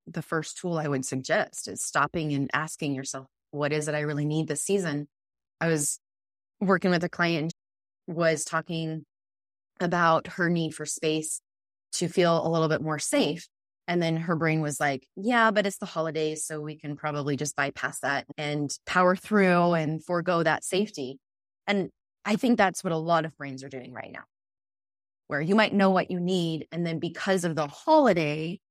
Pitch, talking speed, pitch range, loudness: 160 Hz, 190 wpm, 145-175 Hz, -27 LUFS